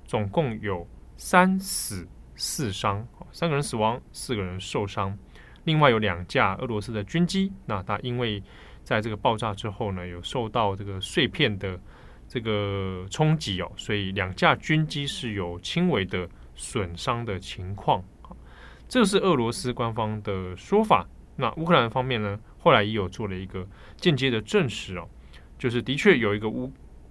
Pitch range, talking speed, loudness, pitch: 95-130 Hz, 240 characters per minute, -26 LUFS, 105 Hz